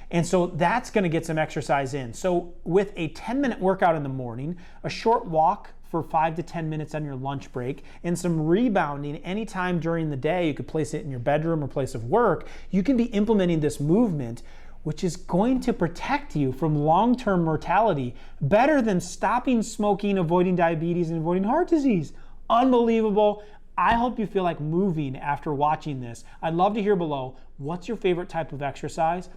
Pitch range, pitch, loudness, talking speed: 150-200 Hz, 170 Hz, -25 LUFS, 190 wpm